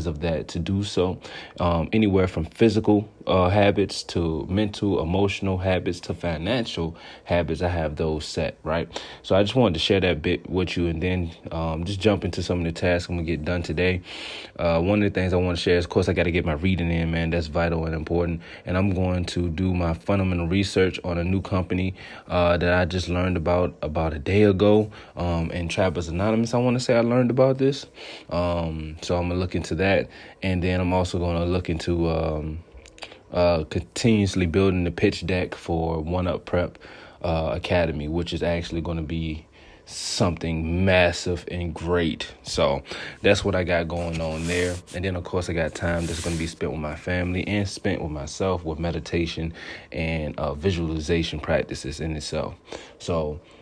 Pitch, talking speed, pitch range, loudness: 85 Hz, 205 wpm, 85-95 Hz, -24 LUFS